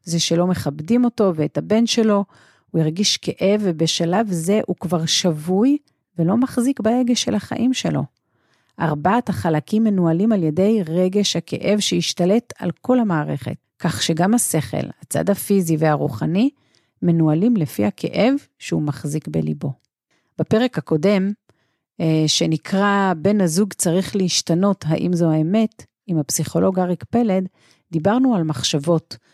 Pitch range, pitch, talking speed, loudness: 160-210 Hz, 180 Hz, 125 wpm, -19 LUFS